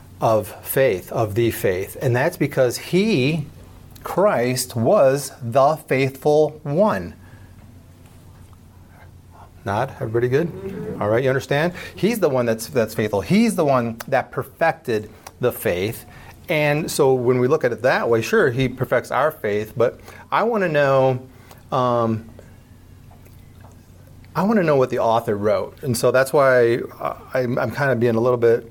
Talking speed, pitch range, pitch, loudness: 155 wpm, 110-135 Hz, 125 Hz, -20 LUFS